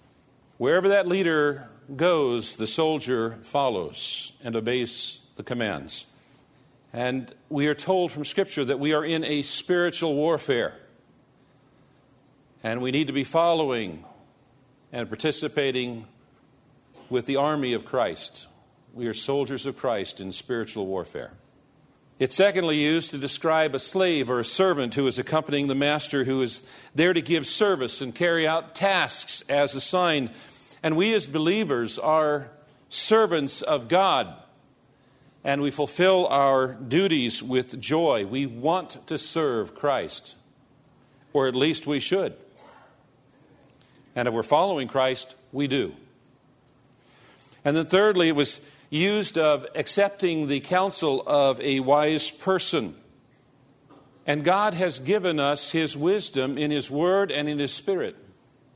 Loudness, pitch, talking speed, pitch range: -24 LUFS, 140 Hz, 135 wpm, 130-160 Hz